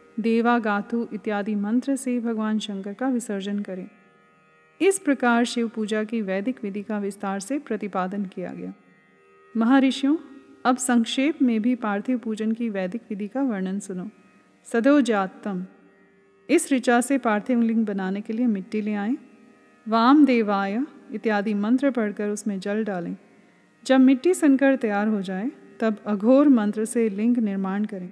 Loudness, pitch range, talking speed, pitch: -23 LUFS, 205-250 Hz, 145 wpm, 220 Hz